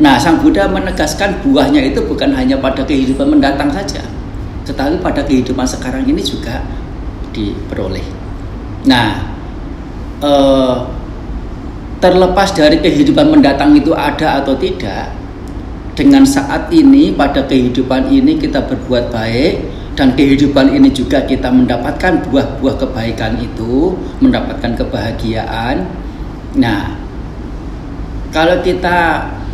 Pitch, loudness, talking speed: 140 Hz, -12 LUFS, 105 wpm